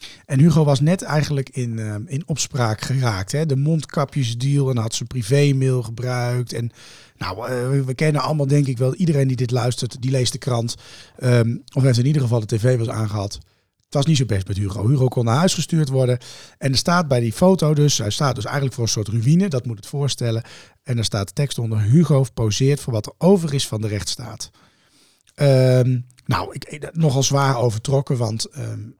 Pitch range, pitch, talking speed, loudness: 115-145 Hz, 130 Hz, 205 wpm, -20 LUFS